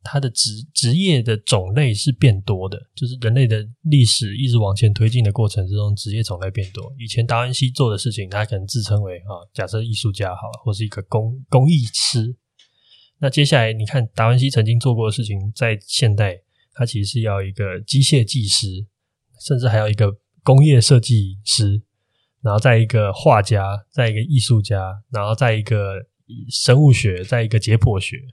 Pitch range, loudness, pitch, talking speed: 105-125 Hz, -18 LUFS, 115 Hz, 285 characters per minute